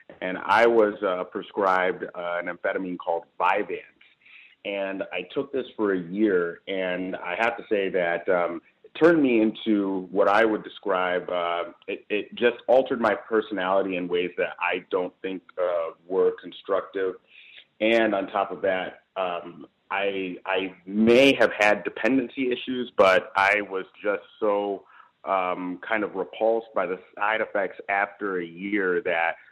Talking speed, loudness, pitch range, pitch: 160 wpm, -25 LUFS, 90-110 Hz, 95 Hz